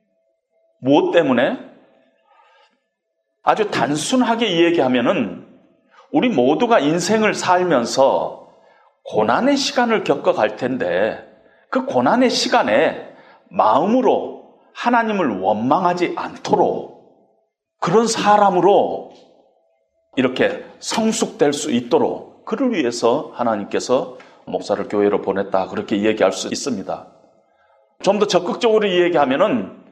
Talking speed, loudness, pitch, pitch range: 240 characters per minute, -18 LUFS, 215 Hz, 170-240 Hz